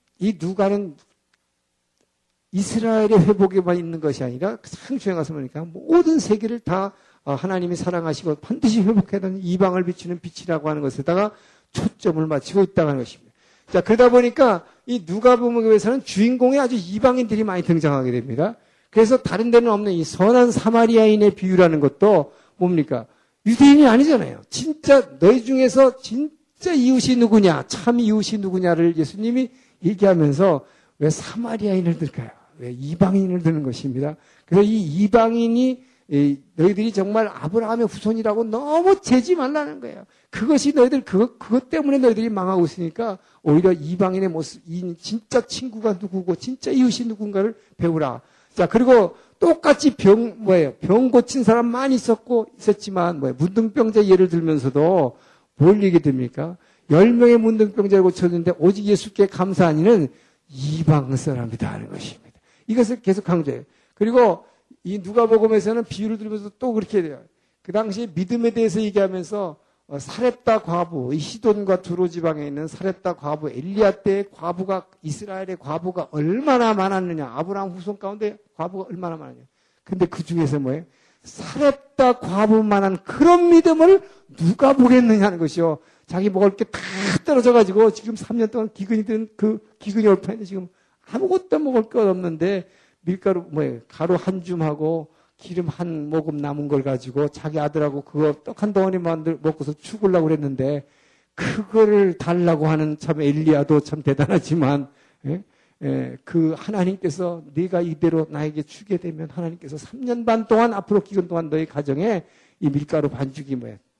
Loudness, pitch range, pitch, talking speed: -19 LUFS, 160-225 Hz, 190 Hz, 350 characters per minute